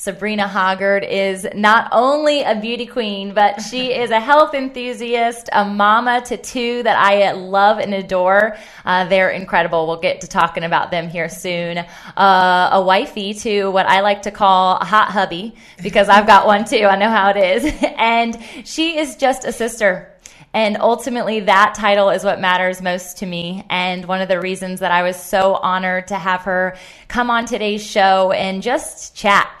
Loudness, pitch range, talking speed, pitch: -16 LUFS, 185-230 Hz, 185 wpm, 200 Hz